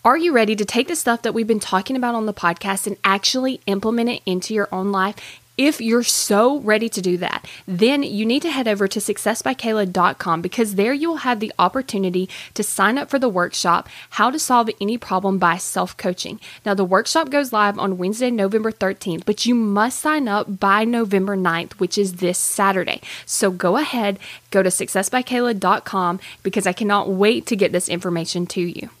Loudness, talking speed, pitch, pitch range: -19 LUFS, 200 wpm, 205 Hz, 190-235 Hz